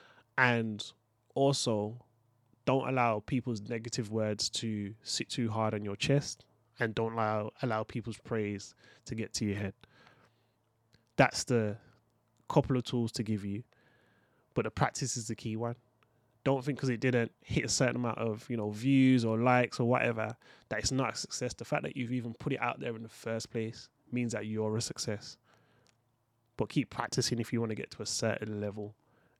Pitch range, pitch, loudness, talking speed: 110-125 Hz, 115 Hz, -33 LUFS, 190 wpm